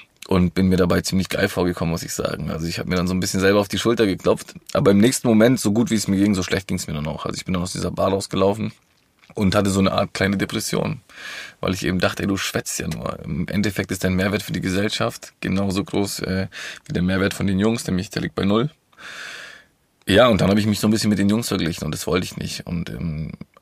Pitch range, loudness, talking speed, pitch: 95-105 Hz, -21 LUFS, 270 wpm, 95 Hz